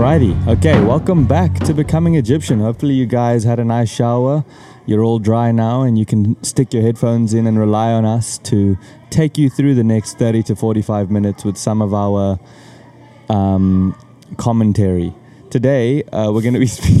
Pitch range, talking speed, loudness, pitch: 105-130 Hz, 185 wpm, -15 LUFS, 115 Hz